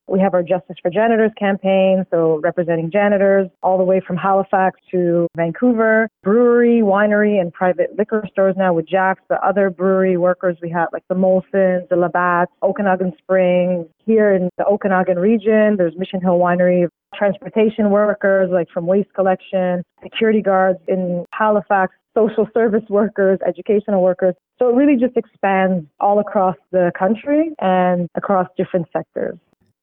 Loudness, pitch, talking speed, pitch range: -17 LUFS, 190 Hz, 155 wpm, 180-205 Hz